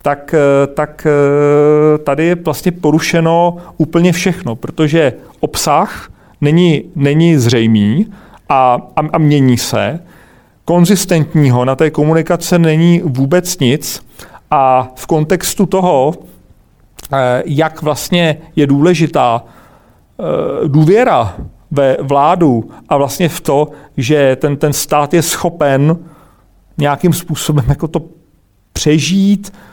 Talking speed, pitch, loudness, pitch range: 100 wpm, 155 Hz, -12 LUFS, 140-170 Hz